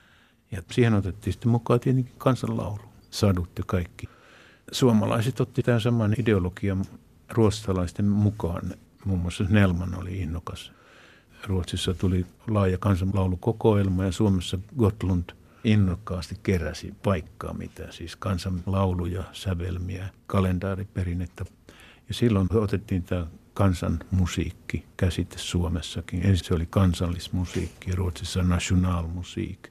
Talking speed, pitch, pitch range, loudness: 105 wpm, 95 Hz, 90-110 Hz, -26 LUFS